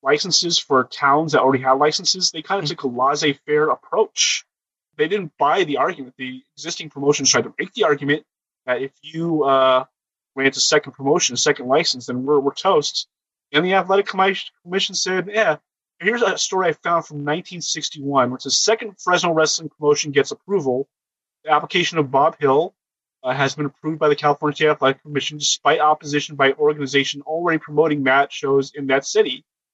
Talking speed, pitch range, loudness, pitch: 180 wpm, 140-170 Hz, -19 LUFS, 150 Hz